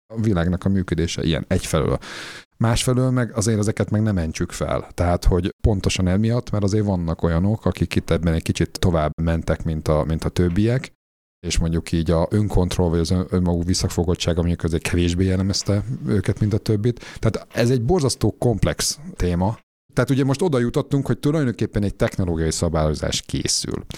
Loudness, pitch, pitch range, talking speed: -21 LUFS, 95 Hz, 85-110 Hz, 170 wpm